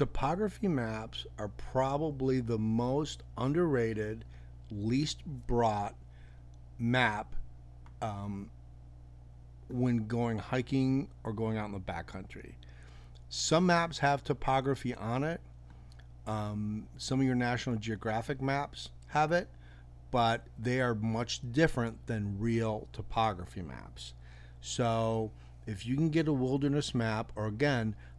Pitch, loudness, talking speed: 110 Hz, -33 LUFS, 115 wpm